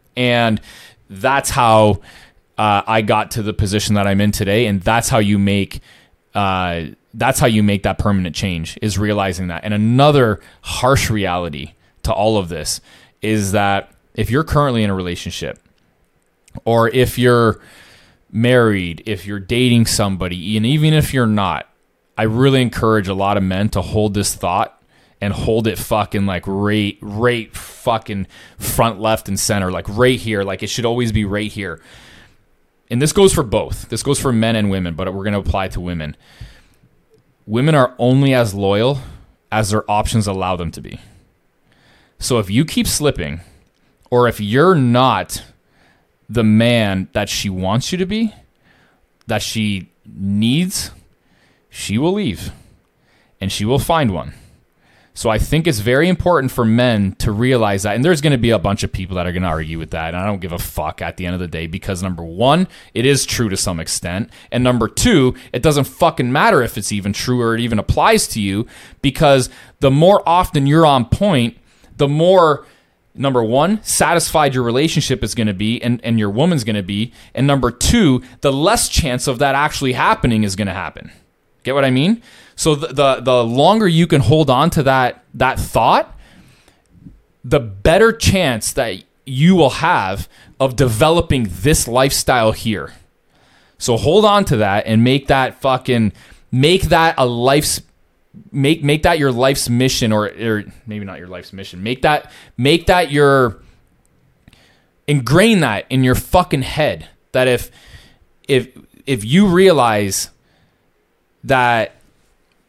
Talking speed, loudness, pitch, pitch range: 175 wpm, -16 LUFS, 115 Hz, 100-135 Hz